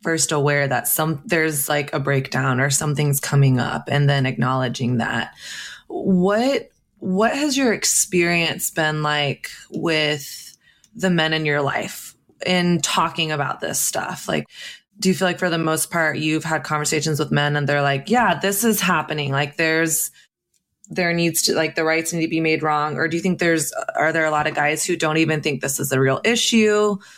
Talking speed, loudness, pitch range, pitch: 195 wpm, -20 LUFS, 145-175 Hz, 155 Hz